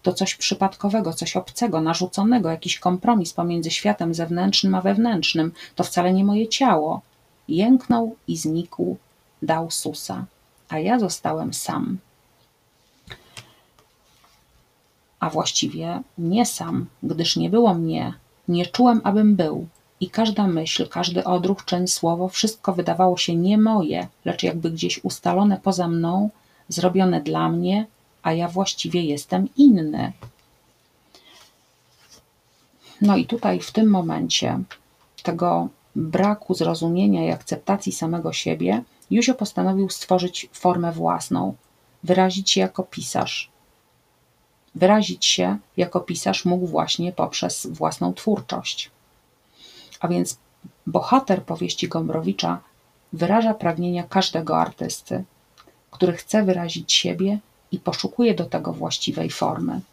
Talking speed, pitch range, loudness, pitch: 115 wpm, 165-200 Hz, -22 LUFS, 180 Hz